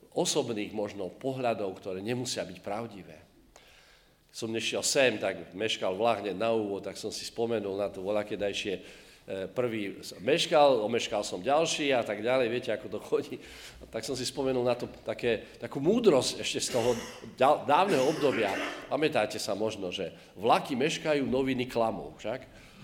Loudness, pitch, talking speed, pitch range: -30 LUFS, 110 Hz, 145 wpm, 100-125 Hz